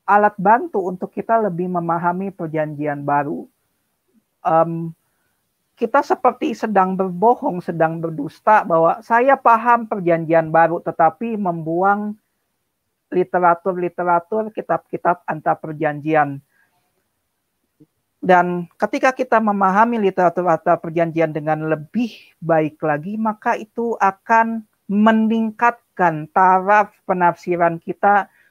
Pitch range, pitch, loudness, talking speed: 165-220 Hz, 180 Hz, -18 LUFS, 95 wpm